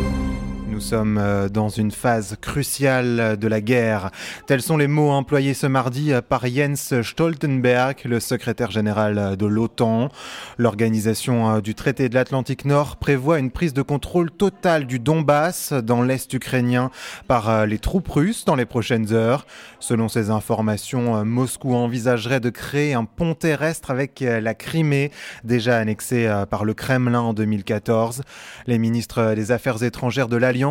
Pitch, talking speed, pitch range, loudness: 125 Hz, 150 wpm, 110-140 Hz, -21 LUFS